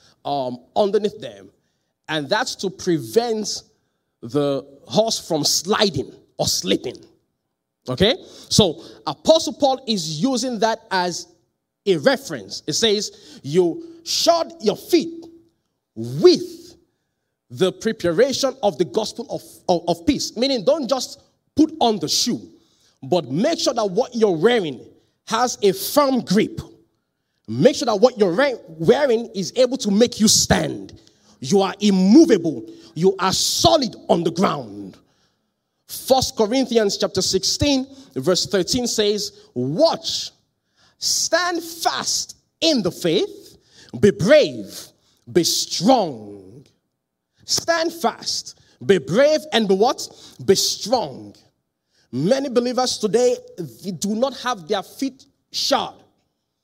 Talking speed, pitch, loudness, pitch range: 120 wpm, 215 Hz, -19 LUFS, 185-270 Hz